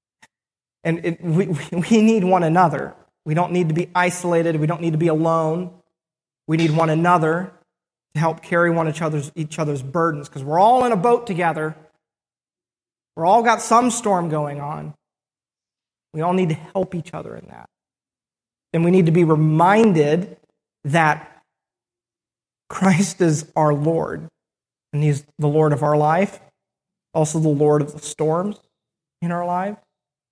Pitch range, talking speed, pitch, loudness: 155-180 Hz, 160 wpm, 165 Hz, -19 LUFS